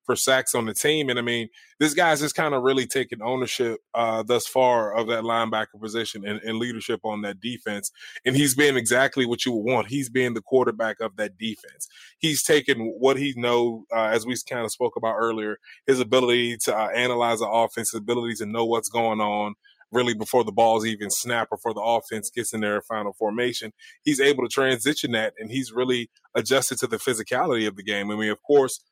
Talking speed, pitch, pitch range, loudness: 215 wpm, 115 Hz, 110-130 Hz, -24 LUFS